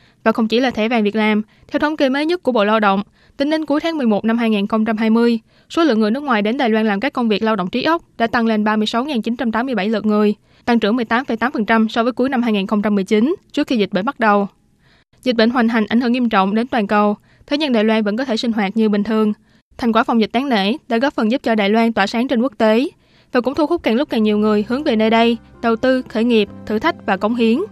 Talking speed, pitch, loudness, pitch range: 265 wpm, 230 Hz, -17 LUFS, 215-250 Hz